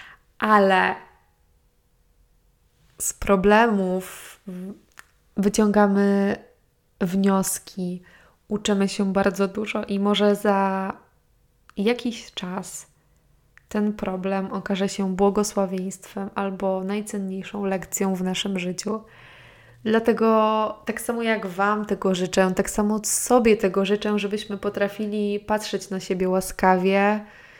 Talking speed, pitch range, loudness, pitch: 95 wpm, 190-210 Hz, -23 LUFS, 200 Hz